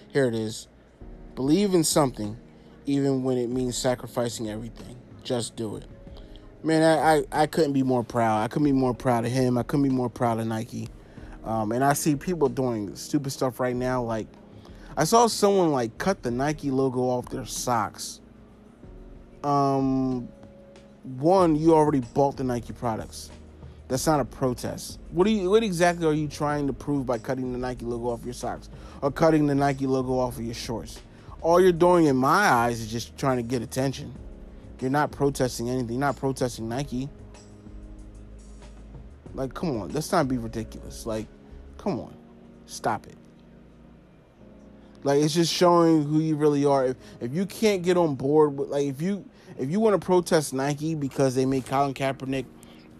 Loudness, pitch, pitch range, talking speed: -25 LUFS, 130 Hz, 115-150 Hz, 180 wpm